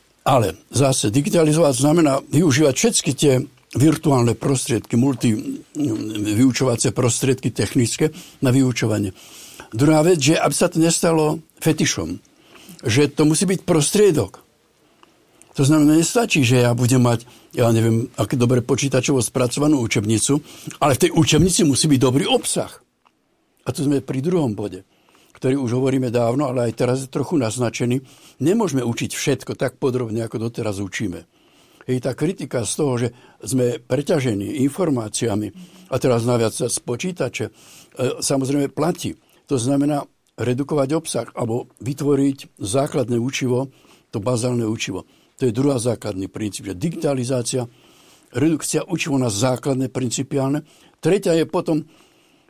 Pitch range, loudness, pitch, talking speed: 125-155 Hz, -20 LUFS, 135 Hz, 135 wpm